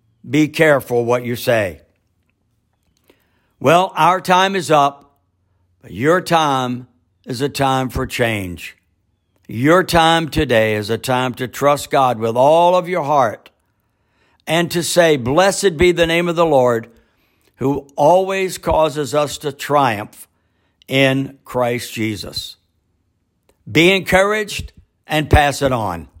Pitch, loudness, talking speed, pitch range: 130 Hz, -16 LUFS, 130 wpm, 105-160 Hz